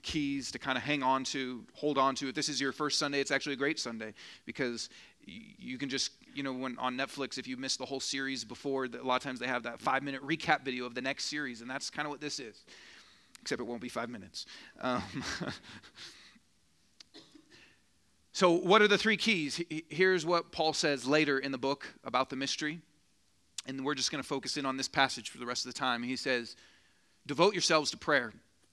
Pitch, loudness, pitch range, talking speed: 135 Hz, -32 LUFS, 130-150 Hz, 220 wpm